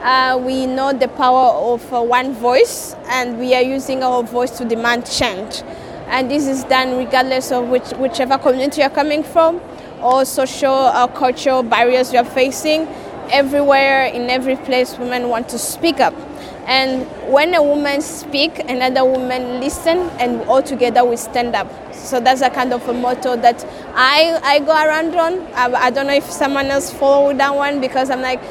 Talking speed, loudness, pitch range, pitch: 185 wpm, -16 LUFS, 250-280 Hz, 260 Hz